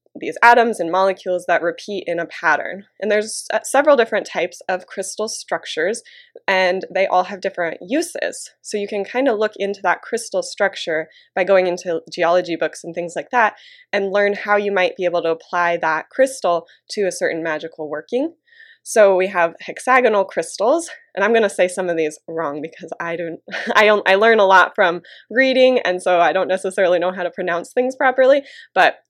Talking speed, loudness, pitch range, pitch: 200 wpm, -18 LUFS, 175-230 Hz, 190 Hz